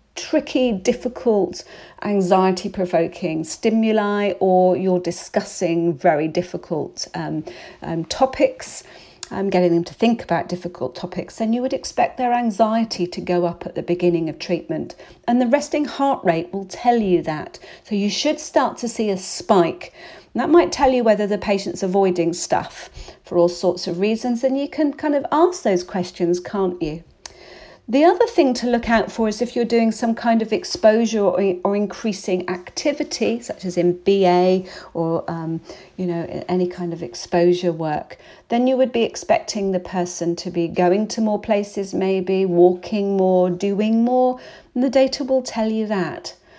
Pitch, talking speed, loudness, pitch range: 200 Hz, 170 wpm, -20 LUFS, 180-235 Hz